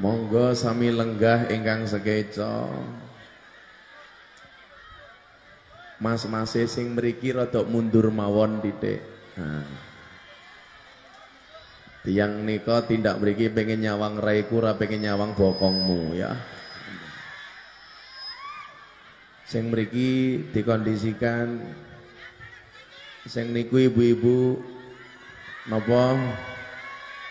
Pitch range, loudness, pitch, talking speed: 105-120 Hz, -25 LUFS, 115 Hz, 70 wpm